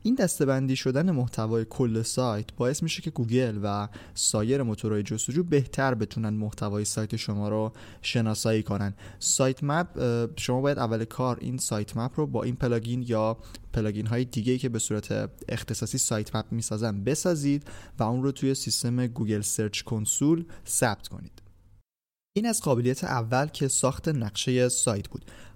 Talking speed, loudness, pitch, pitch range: 155 wpm, -27 LUFS, 115 Hz, 105-130 Hz